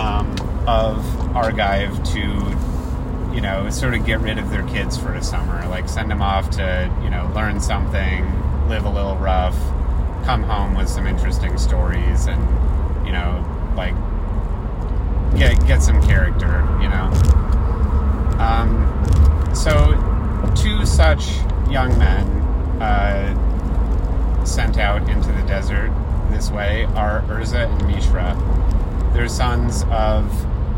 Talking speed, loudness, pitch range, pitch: 125 wpm, -19 LUFS, 70-90 Hz, 75 Hz